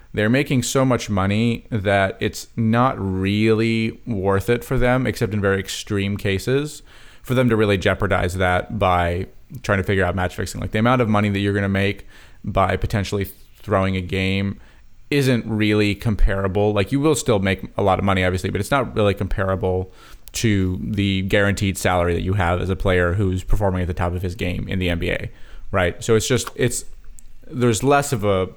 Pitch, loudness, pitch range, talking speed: 100 Hz, -20 LUFS, 95-115 Hz, 195 wpm